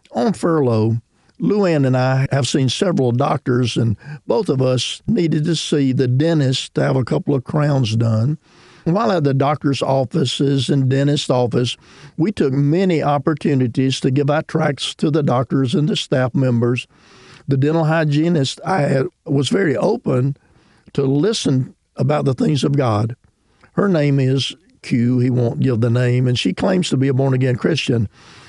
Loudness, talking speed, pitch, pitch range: -18 LUFS, 170 wpm, 140 Hz, 125-150 Hz